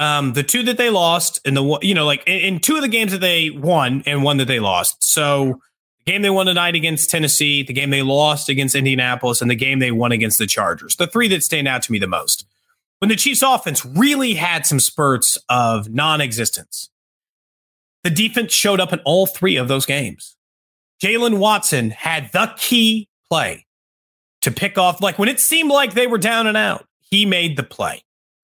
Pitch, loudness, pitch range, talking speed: 160 Hz, -16 LUFS, 135-200 Hz, 210 wpm